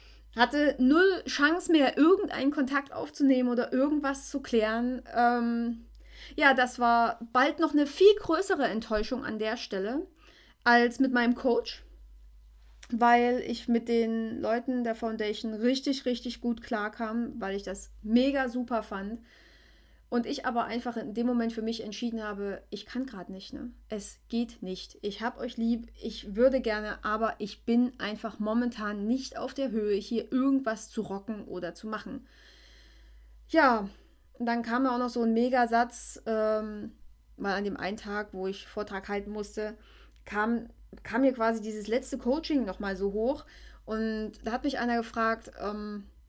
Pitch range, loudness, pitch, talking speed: 215-255 Hz, -29 LUFS, 235 Hz, 160 wpm